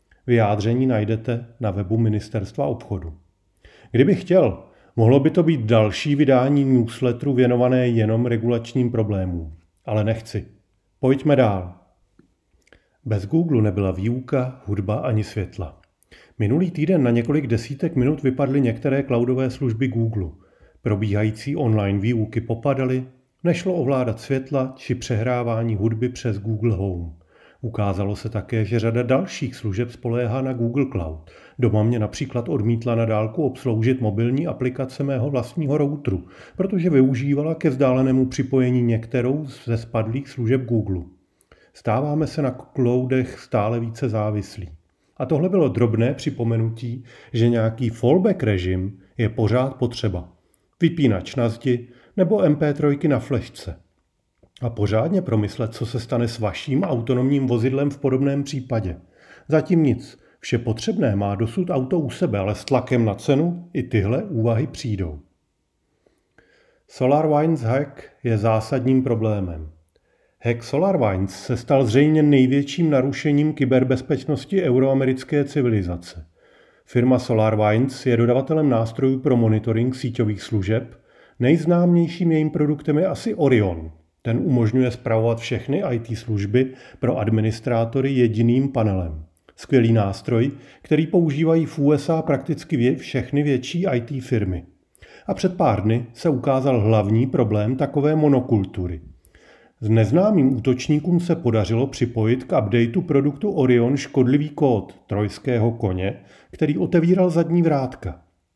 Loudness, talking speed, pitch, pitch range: -21 LUFS, 125 wpm, 120 Hz, 110-140 Hz